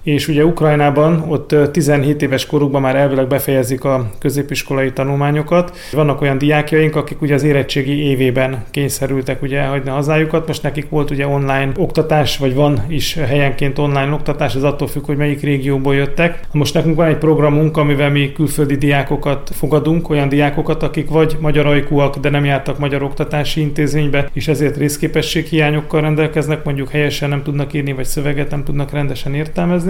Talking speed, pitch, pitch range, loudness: 165 wpm, 145 Hz, 140-150 Hz, -15 LUFS